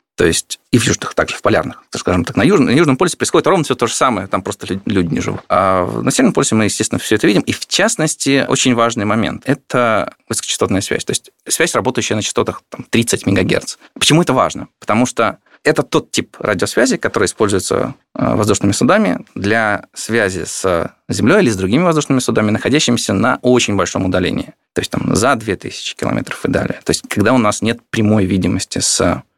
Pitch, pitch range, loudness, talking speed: 120 Hz, 105-135 Hz, -15 LUFS, 200 wpm